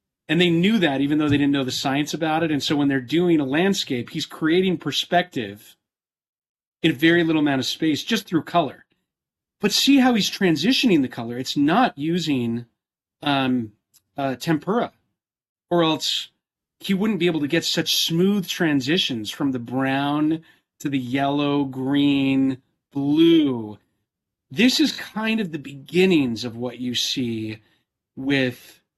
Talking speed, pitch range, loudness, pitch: 155 wpm, 135-170 Hz, -21 LUFS, 150 Hz